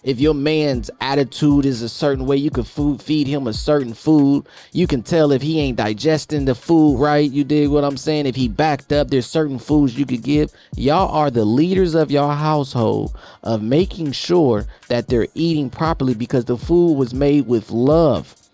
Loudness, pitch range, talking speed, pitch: -18 LUFS, 130-155 Hz, 200 wpm, 145 Hz